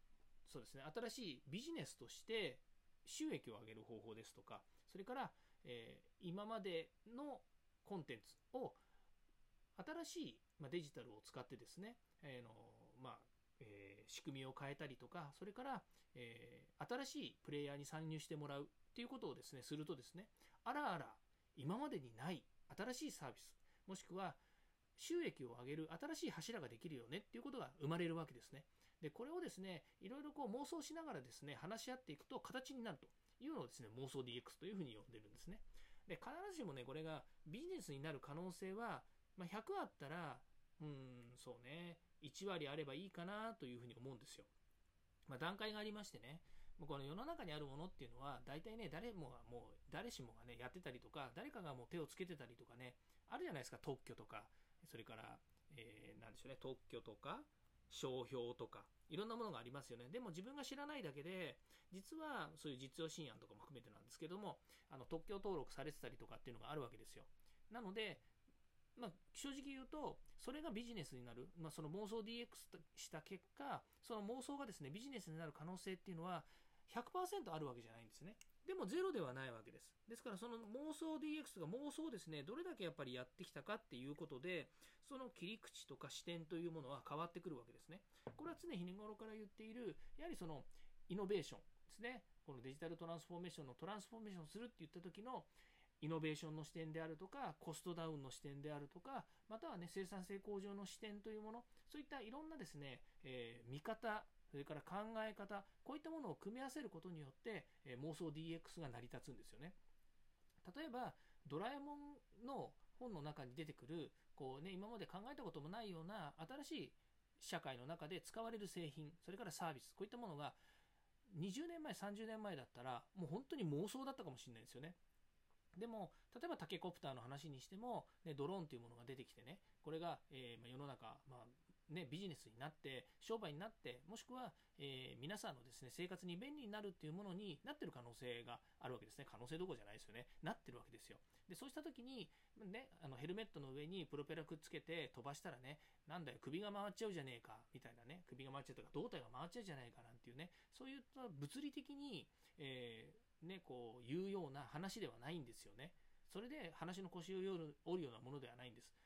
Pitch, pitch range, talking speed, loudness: 165 Hz, 140-215 Hz, 420 characters per minute, -53 LUFS